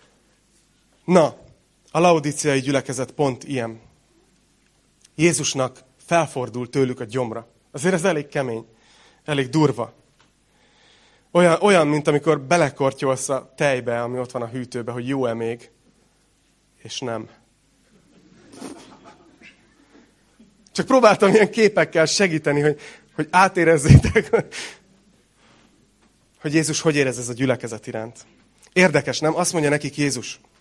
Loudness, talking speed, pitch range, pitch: -20 LUFS, 110 wpm, 125-160 Hz, 140 Hz